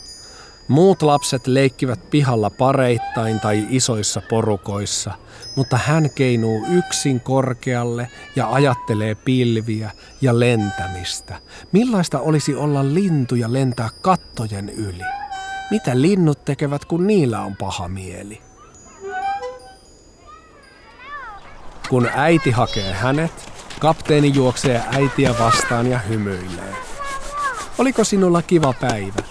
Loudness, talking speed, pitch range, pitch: -19 LUFS, 100 wpm, 110-155 Hz, 130 Hz